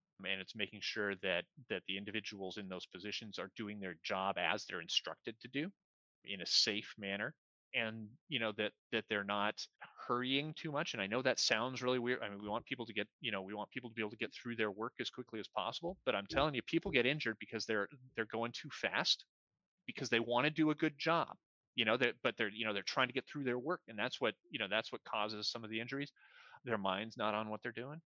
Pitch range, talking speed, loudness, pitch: 105-125 Hz, 255 wpm, -39 LUFS, 110 Hz